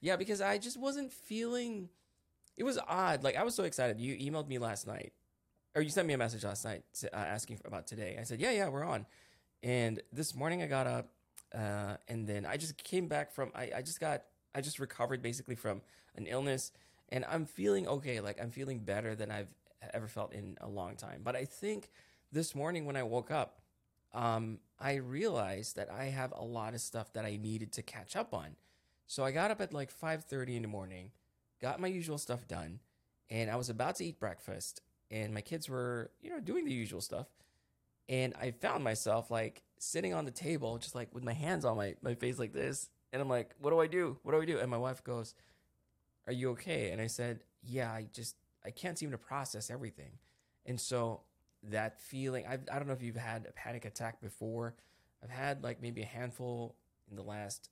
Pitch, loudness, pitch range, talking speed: 120 Hz, -39 LUFS, 110-140 Hz, 220 wpm